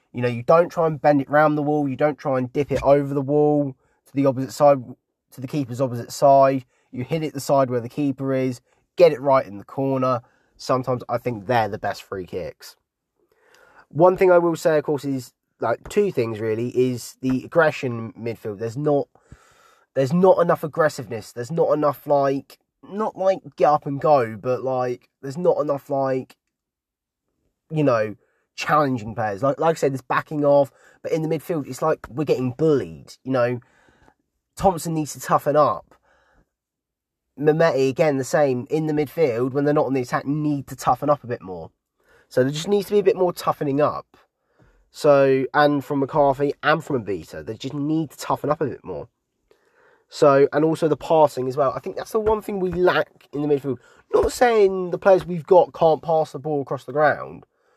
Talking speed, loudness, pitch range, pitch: 205 wpm, -21 LUFS, 130-160 Hz, 145 Hz